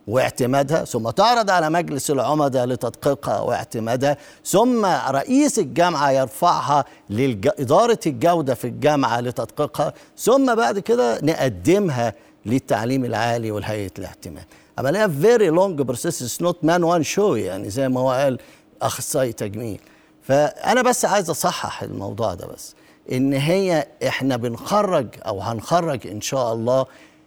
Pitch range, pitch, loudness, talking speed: 125-175 Hz, 140 Hz, -20 LUFS, 130 wpm